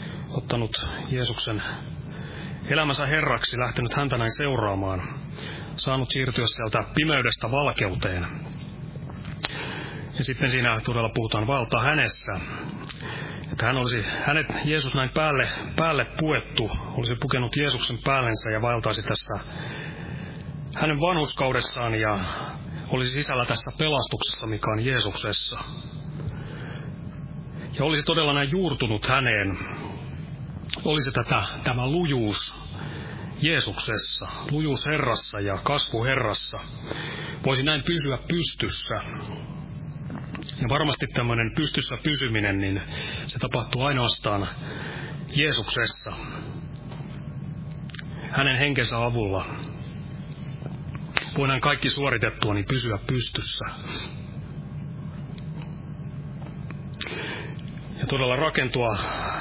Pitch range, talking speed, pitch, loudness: 120-155 Hz, 90 wpm, 140 Hz, -25 LUFS